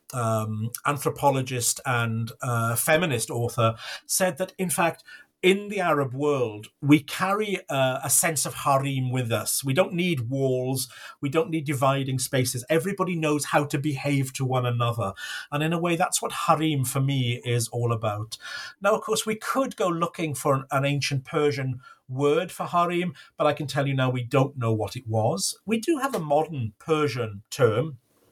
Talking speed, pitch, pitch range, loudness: 180 wpm, 140 Hz, 125-165 Hz, -25 LUFS